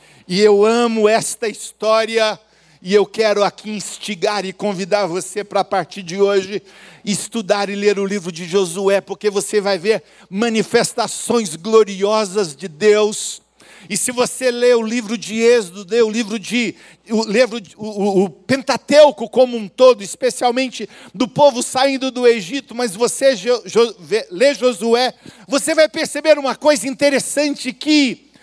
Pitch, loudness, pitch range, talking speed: 220 Hz, -17 LUFS, 200-245 Hz, 150 wpm